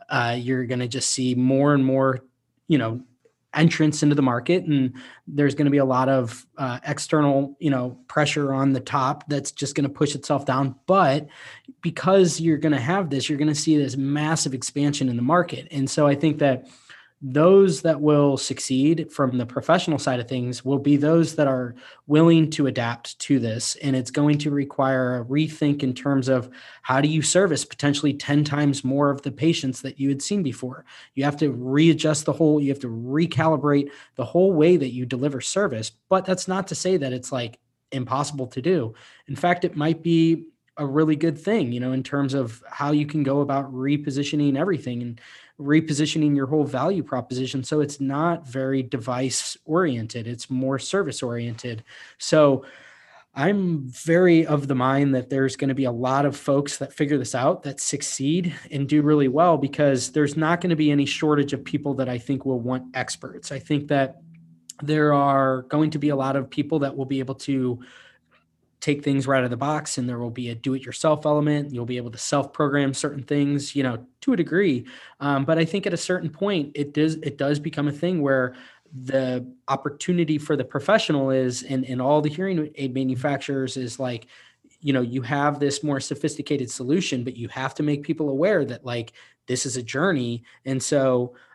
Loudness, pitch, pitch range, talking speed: -23 LUFS, 140 Hz, 130-150 Hz, 205 wpm